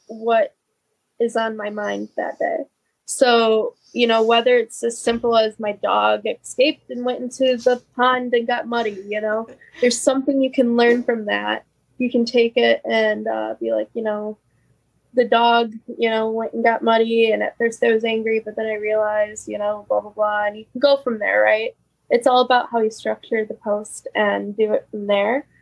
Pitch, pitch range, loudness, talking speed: 225 Hz, 210-245 Hz, -20 LUFS, 205 wpm